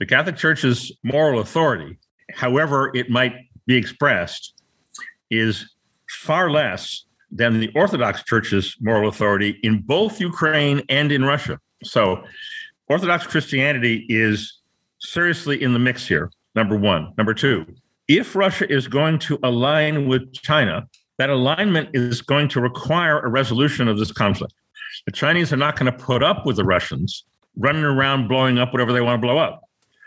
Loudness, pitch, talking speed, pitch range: -19 LUFS, 130 Hz, 155 wpm, 120-150 Hz